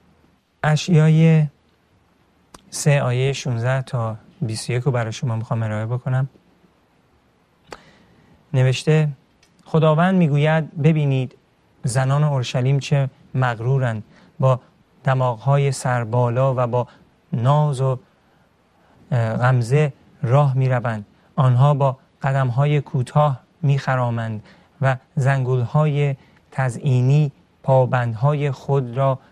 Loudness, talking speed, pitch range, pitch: -20 LUFS, 85 wpm, 125-145 Hz, 135 Hz